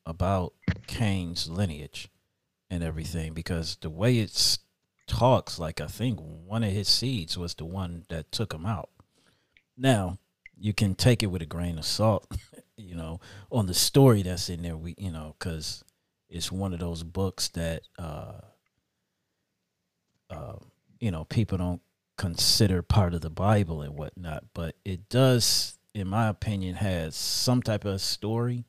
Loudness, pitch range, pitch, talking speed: -28 LUFS, 85-105 Hz, 95 Hz, 160 wpm